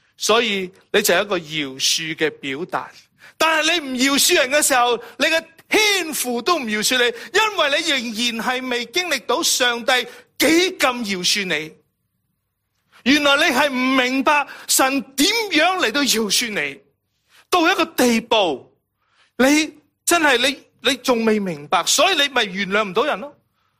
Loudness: -18 LUFS